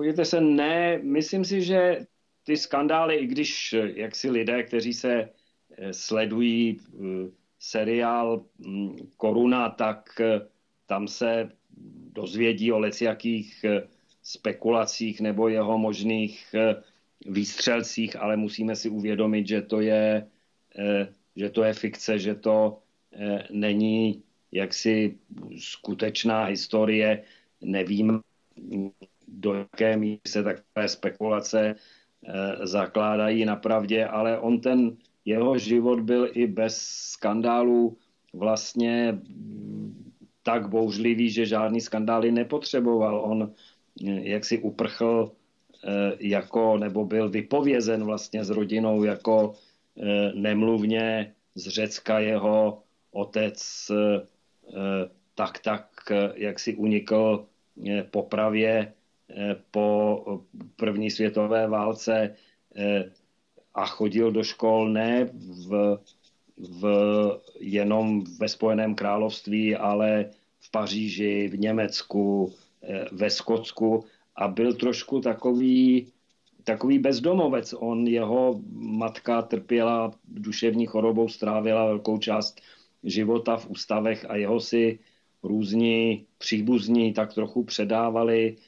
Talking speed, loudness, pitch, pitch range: 100 wpm, -26 LUFS, 110 Hz, 105-115 Hz